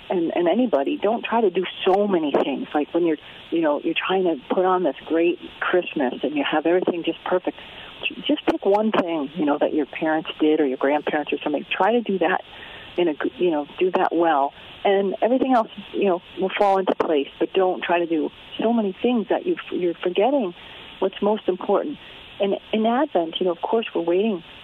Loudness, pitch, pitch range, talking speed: -22 LUFS, 190 Hz, 170-230 Hz, 215 wpm